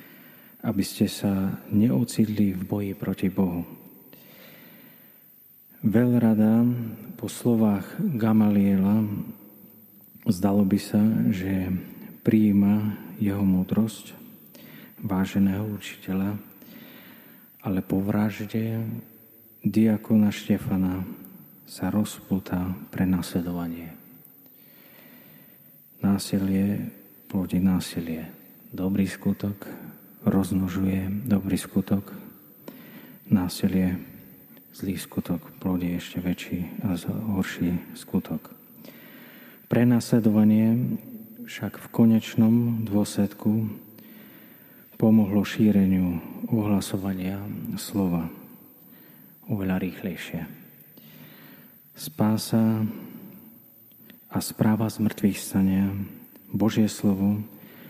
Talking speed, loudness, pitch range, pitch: 70 wpm, -25 LUFS, 95-110 Hz, 100 Hz